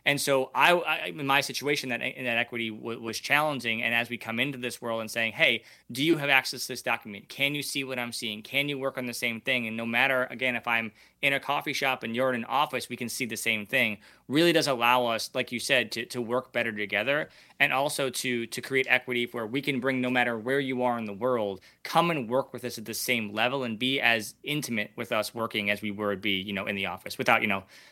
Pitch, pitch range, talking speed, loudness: 125 Hz, 115-135 Hz, 265 wpm, -27 LUFS